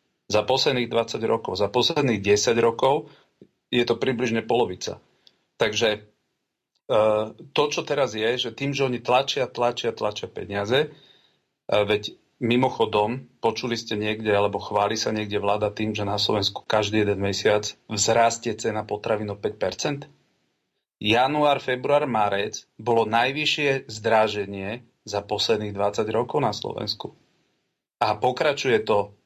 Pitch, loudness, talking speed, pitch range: 110 Hz, -24 LUFS, 125 wpm, 105-125 Hz